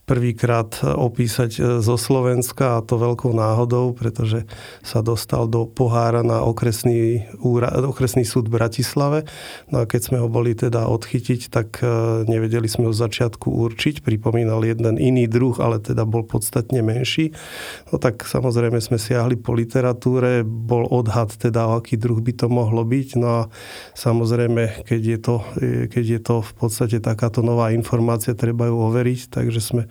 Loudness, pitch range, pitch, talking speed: -20 LUFS, 115-125 Hz, 120 Hz, 155 wpm